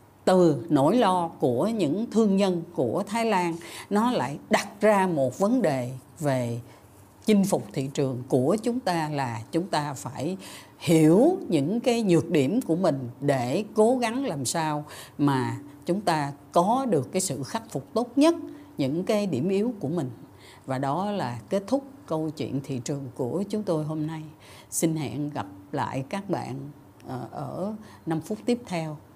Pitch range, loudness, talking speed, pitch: 135-200 Hz, -26 LUFS, 170 wpm, 160 Hz